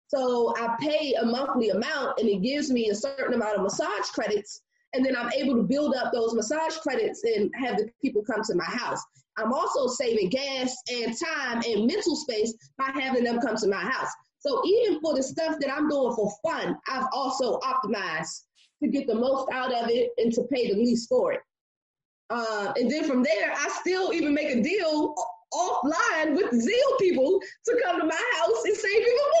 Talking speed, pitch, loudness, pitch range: 205 wpm, 270 Hz, -26 LUFS, 235-330 Hz